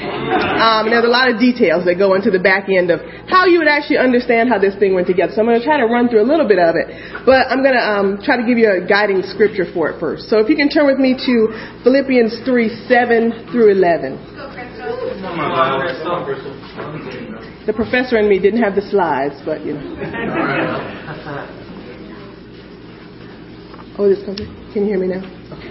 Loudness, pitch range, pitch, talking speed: -15 LUFS, 195-245 Hz, 220 Hz, 195 wpm